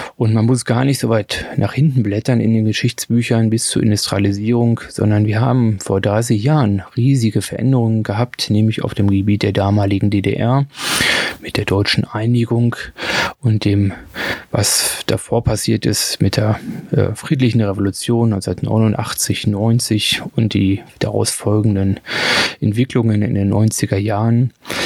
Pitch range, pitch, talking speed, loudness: 105-120 Hz, 110 Hz, 140 wpm, -16 LUFS